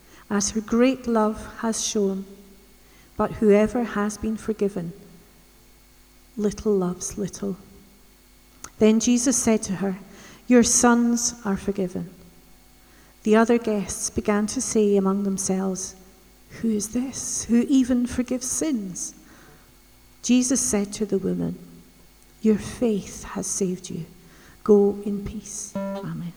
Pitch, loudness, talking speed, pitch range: 205 Hz, -23 LUFS, 120 wpm, 190-225 Hz